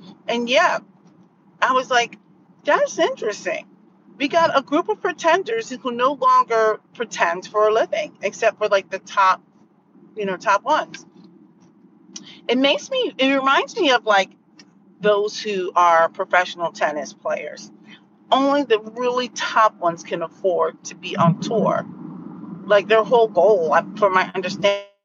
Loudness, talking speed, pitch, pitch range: -20 LUFS, 150 wpm, 215 Hz, 190-265 Hz